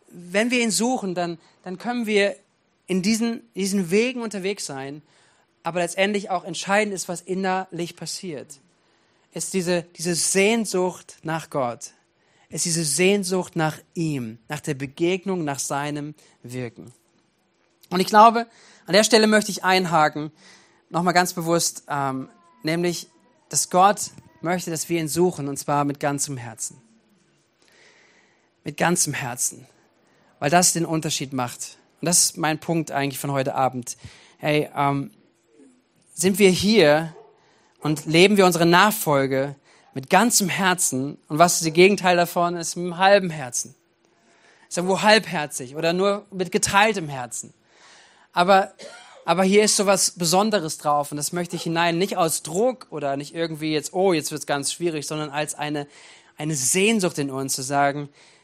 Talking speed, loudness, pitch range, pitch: 155 wpm, -21 LUFS, 150-190 Hz, 170 Hz